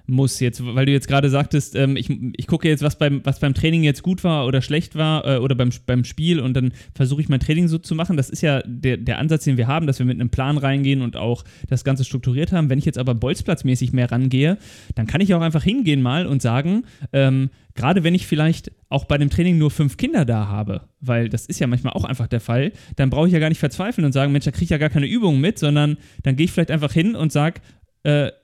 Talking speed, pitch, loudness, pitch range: 265 wpm, 140 Hz, -20 LUFS, 130-155 Hz